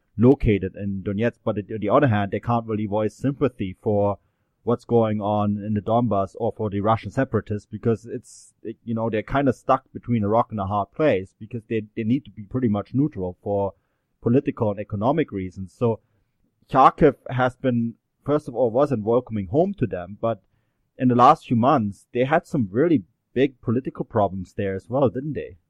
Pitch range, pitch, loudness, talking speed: 105-125 Hz, 110 Hz, -23 LUFS, 195 wpm